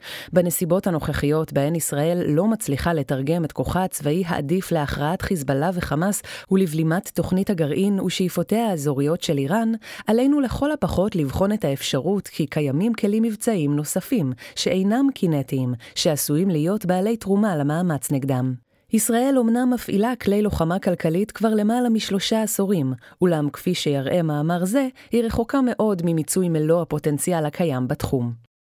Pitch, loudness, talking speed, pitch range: 175 Hz, -22 LUFS, 130 wpm, 150-210 Hz